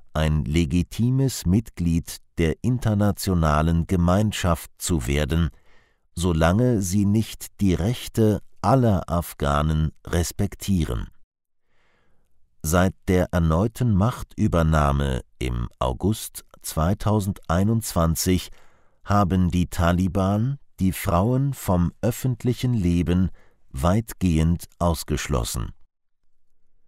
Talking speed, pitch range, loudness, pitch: 75 wpm, 80-105 Hz, -23 LUFS, 90 Hz